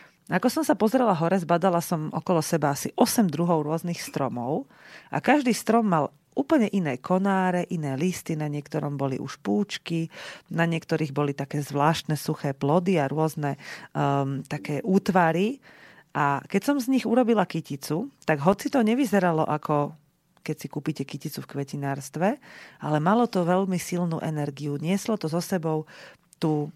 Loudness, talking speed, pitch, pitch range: -26 LUFS, 155 wpm, 165 Hz, 150-190 Hz